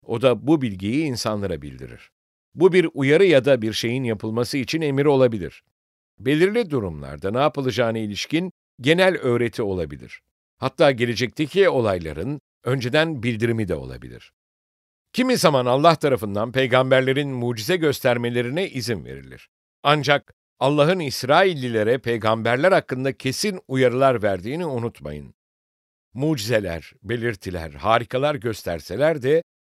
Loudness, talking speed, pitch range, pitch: -21 LUFS, 110 wpm, 105-145 Hz, 125 Hz